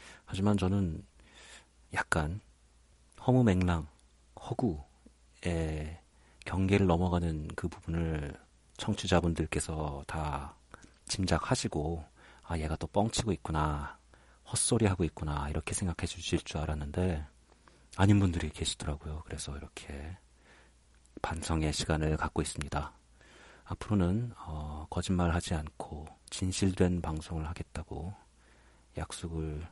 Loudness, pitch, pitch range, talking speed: -33 LUFS, 80 Hz, 75-90 Hz, 250 characters per minute